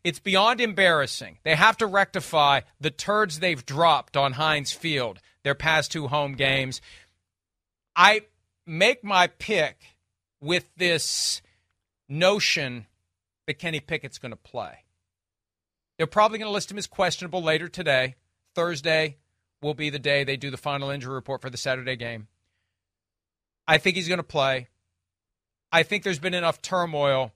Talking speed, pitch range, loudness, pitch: 145 wpm, 110-175 Hz, -24 LUFS, 145 Hz